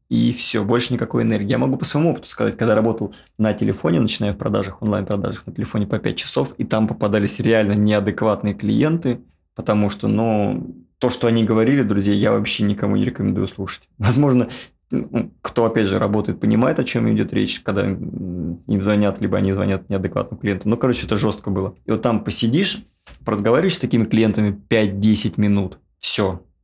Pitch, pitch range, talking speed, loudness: 105 Hz, 100-115 Hz, 175 wpm, -20 LUFS